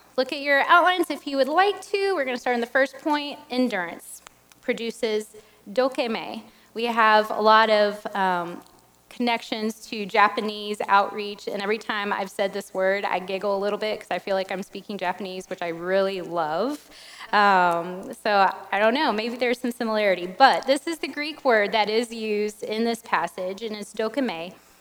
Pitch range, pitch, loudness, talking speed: 195-250 Hz, 215 Hz, -23 LUFS, 185 wpm